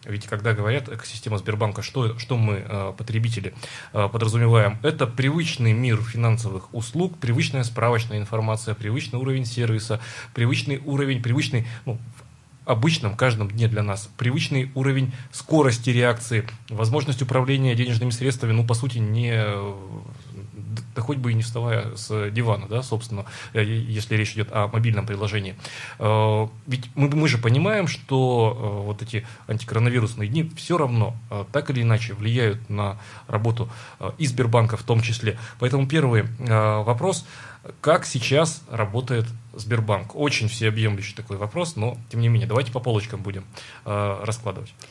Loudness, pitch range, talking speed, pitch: -23 LUFS, 110-130 Hz, 135 wpm, 115 Hz